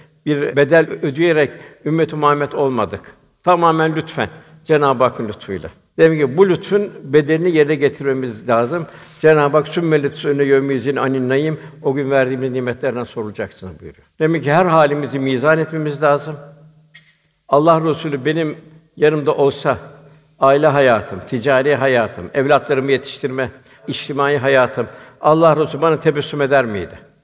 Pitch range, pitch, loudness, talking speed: 135-155 Hz, 145 Hz, -16 LUFS, 125 wpm